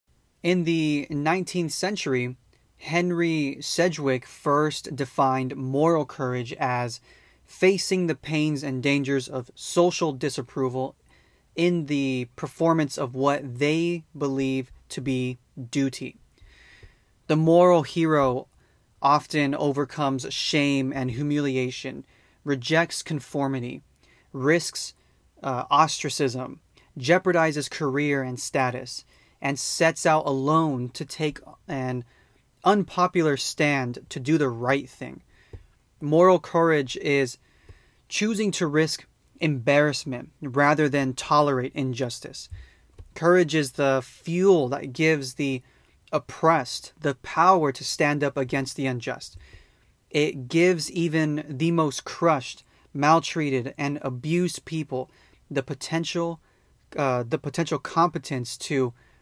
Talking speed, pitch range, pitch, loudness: 105 wpm, 130-160 Hz, 145 Hz, -24 LUFS